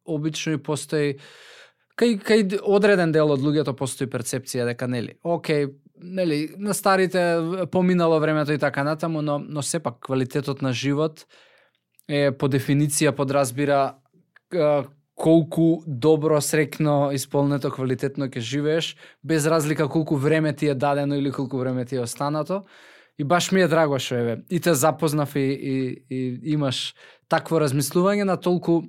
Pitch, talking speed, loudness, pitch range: 150 Hz, 150 wpm, -23 LUFS, 140-165 Hz